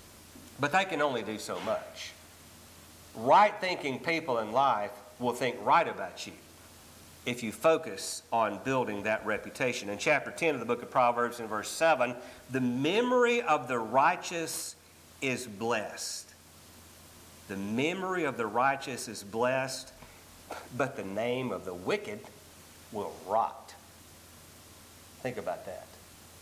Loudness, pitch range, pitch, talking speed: -30 LUFS, 85-135 Hz, 115 Hz, 135 wpm